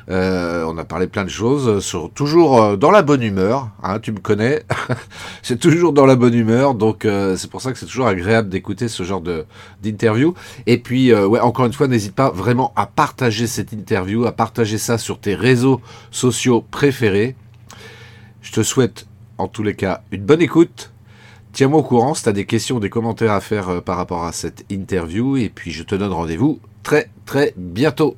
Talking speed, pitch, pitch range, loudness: 205 wpm, 110 Hz, 100-125 Hz, -17 LUFS